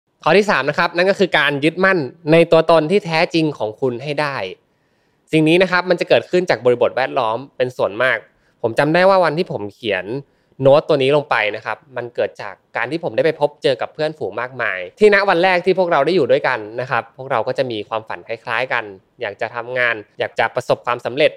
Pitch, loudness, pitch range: 160 Hz, -17 LUFS, 125-185 Hz